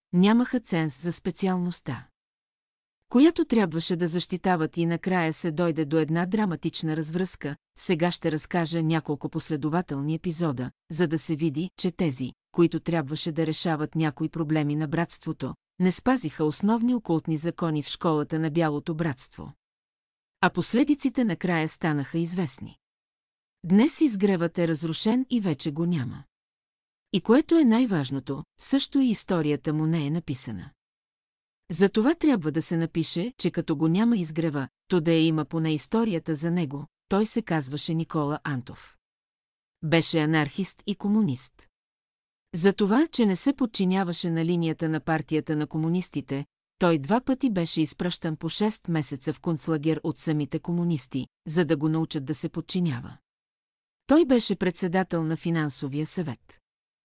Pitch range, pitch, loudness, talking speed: 155-185 Hz, 165 Hz, -26 LUFS, 145 wpm